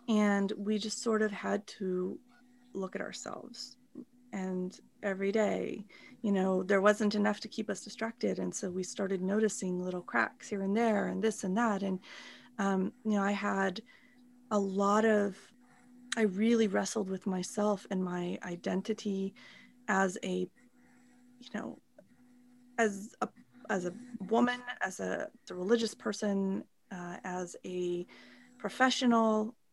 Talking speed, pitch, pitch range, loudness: 145 wpm, 210 Hz, 195-240 Hz, -33 LUFS